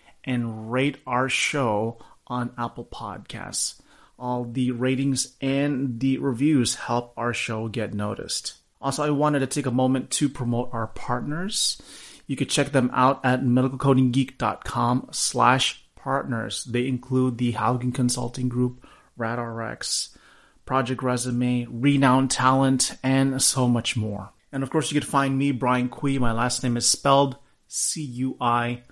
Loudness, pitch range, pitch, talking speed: -24 LUFS, 120-135 Hz, 125 Hz, 140 wpm